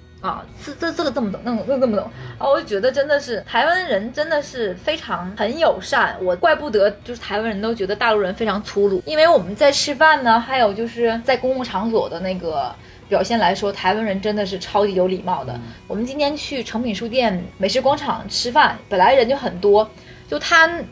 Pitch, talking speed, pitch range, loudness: 225 Hz, 325 characters per minute, 195-275 Hz, -19 LUFS